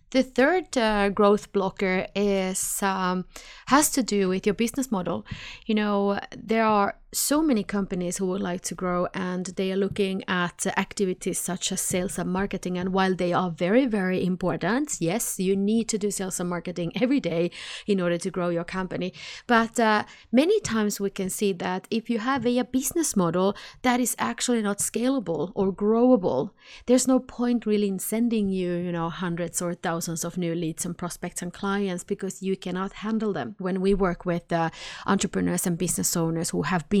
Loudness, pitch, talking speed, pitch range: -25 LUFS, 190 Hz, 190 wpm, 180-220 Hz